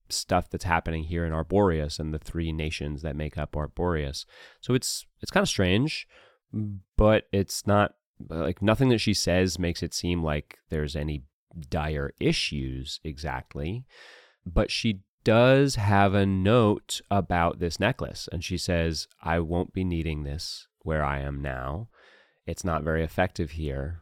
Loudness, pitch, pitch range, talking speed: -27 LUFS, 85 Hz, 75-100 Hz, 155 wpm